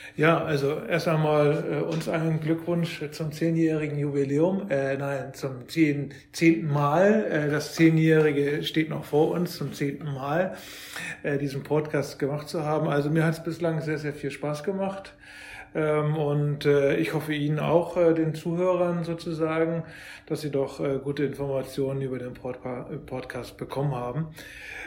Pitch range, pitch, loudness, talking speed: 140-165 Hz, 150 Hz, -26 LUFS, 160 wpm